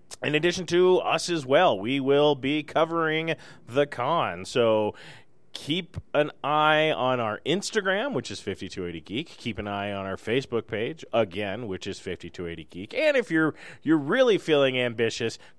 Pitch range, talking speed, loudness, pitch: 105-160 Hz, 160 wpm, -25 LUFS, 135 Hz